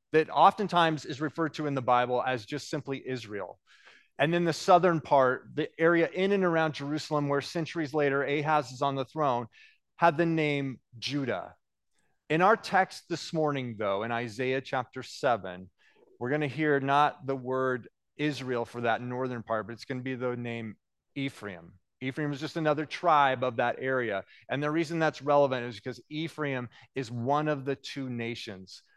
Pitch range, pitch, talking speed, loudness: 125-155 Hz, 140 Hz, 175 wpm, -29 LUFS